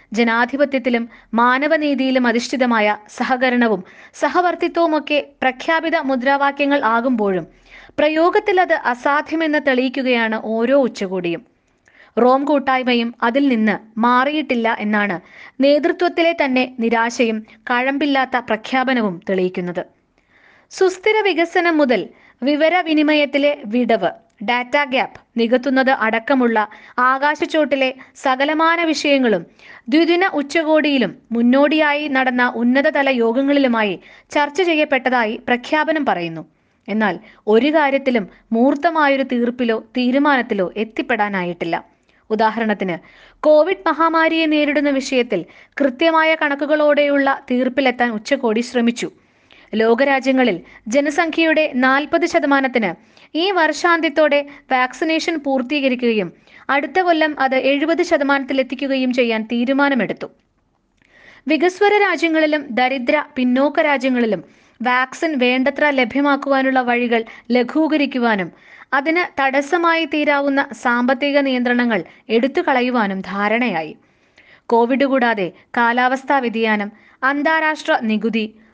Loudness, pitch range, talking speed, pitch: -17 LUFS, 235-300 Hz, 80 wpm, 265 Hz